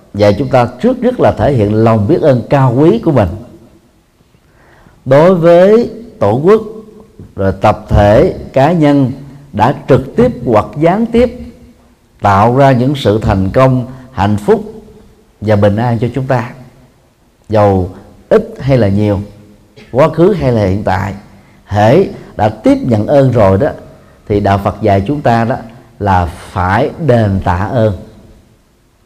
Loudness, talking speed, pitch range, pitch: -11 LUFS, 155 wpm, 105-140 Hz, 120 Hz